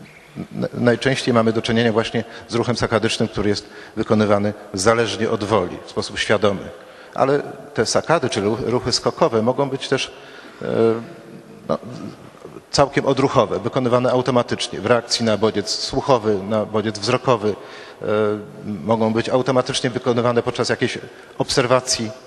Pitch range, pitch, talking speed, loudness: 110-125 Hz, 115 Hz, 130 wpm, -20 LUFS